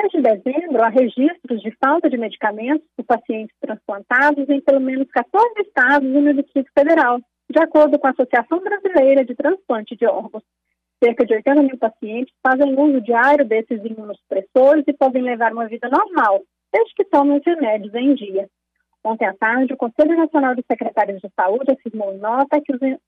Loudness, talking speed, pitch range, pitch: -17 LUFS, 170 wpm, 230-295 Hz, 265 Hz